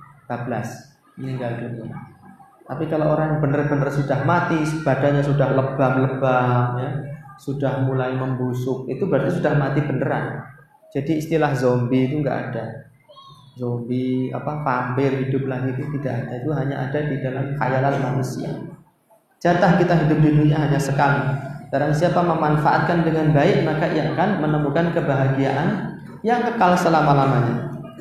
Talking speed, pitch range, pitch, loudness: 135 wpm, 130-155 Hz, 140 Hz, -21 LUFS